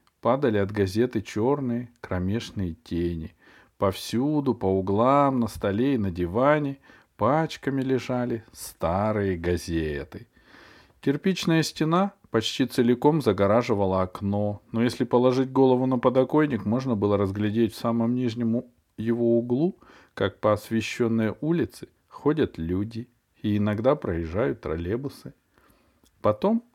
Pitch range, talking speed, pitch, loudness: 100-130 Hz, 110 wpm, 115 Hz, -25 LUFS